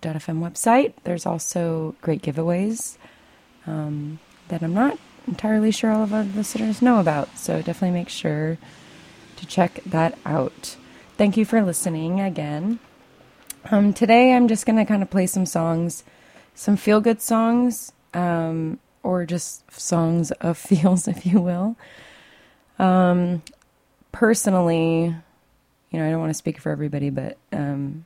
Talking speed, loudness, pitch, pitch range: 145 wpm, -22 LUFS, 180 Hz, 165-215 Hz